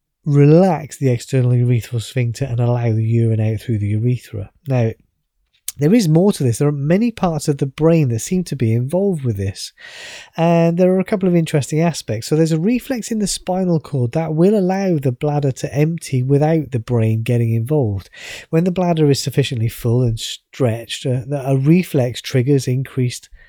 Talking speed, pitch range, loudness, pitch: 185 wpm, 120-165 Hz, -17 LUFS, 140 Hz